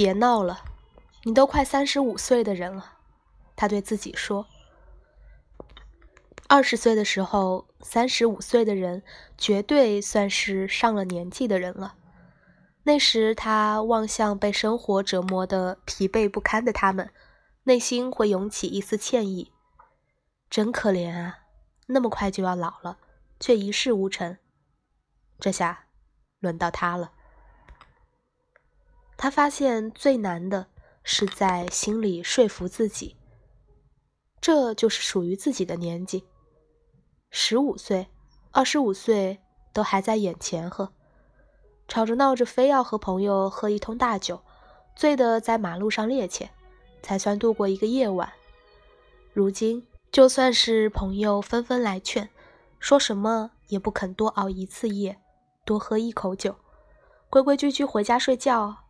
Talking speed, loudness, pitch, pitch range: 195 characters per minute, -24 LUFS, 210 Hz, 190-235 Hz